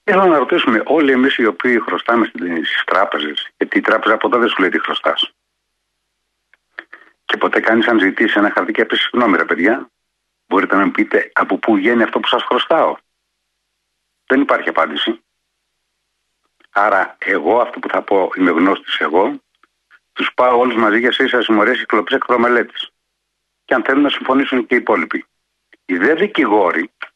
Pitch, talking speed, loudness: 280 Hz, 160 wpm, -15 LUFS